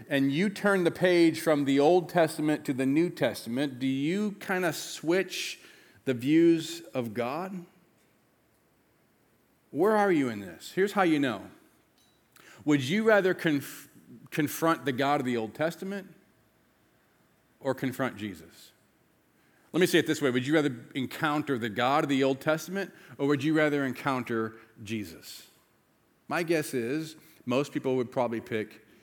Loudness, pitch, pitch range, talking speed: -28 LUFS, 150 Hz, 130-170 Hz, 155 wpm